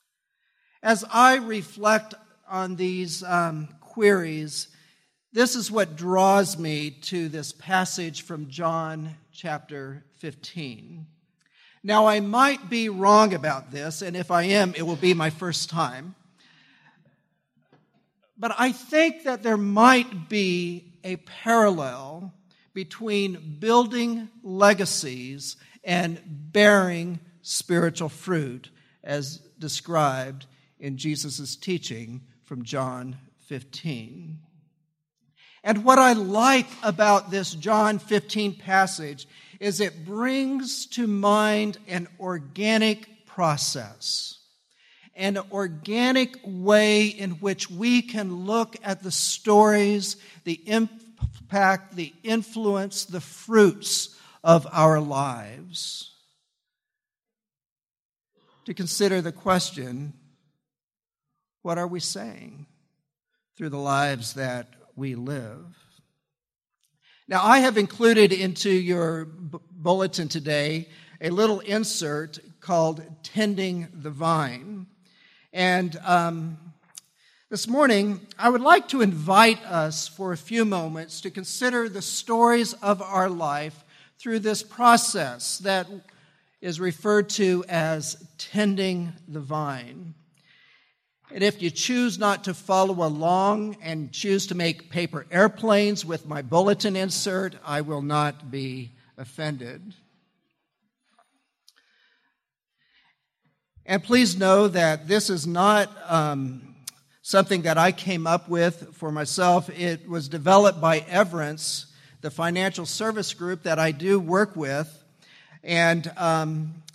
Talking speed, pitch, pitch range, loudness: 110 wpm, 180 Hz, 155-205 Hz, -23 LUFS